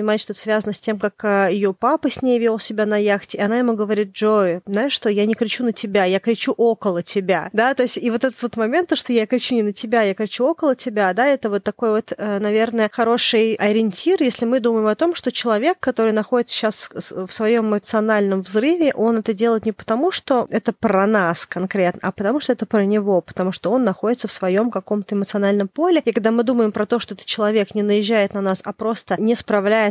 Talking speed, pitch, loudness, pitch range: 225 wpm, 220 Hz, -19 LUFS, 205-235 Hz